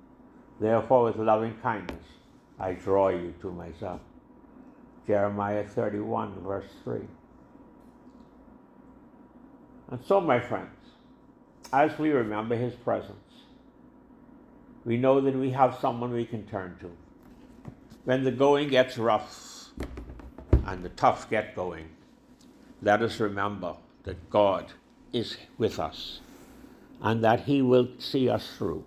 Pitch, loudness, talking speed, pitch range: 120 Hz, -28 LUFS, 120 wpm, 100-155 Hz